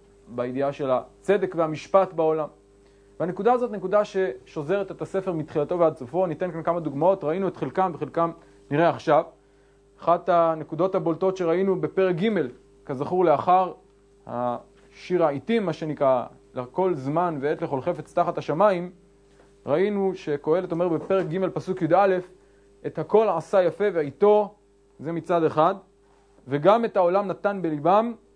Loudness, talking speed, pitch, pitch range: -24 LUFS, 135 wpm, 165 Hz, 145-190 Hz